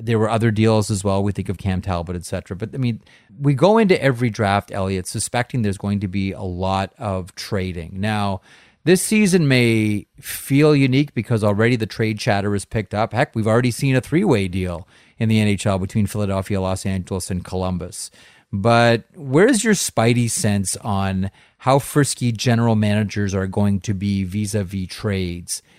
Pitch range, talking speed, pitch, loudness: 95-120 Hz, 180 wpm, 105 Hz, -20 LUFS